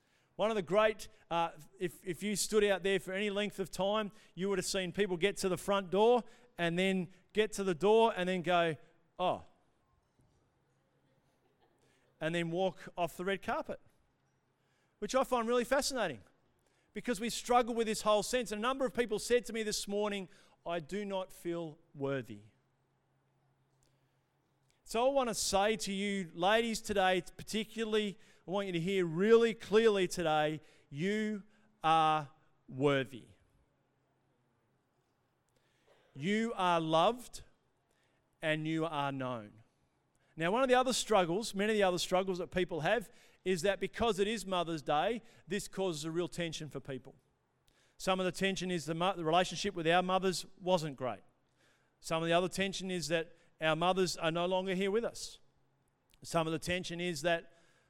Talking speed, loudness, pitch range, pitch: 165 wpm, -34 LUFS, 160-210 Hz, 185 Hz